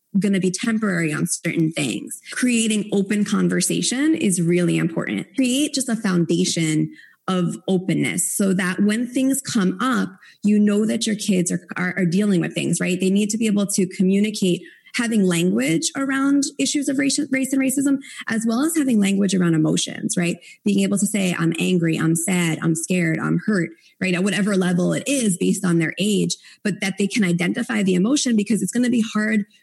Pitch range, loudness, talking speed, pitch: 180-225 Hz, -20 LUFS, 195 wpm, 200 Hz